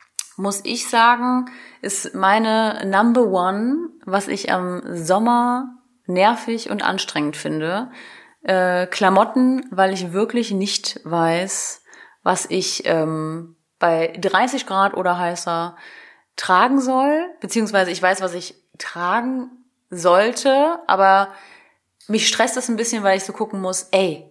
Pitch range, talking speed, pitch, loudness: 185-240 Hz, 125 wpm, 195 Hz, -19 LUFS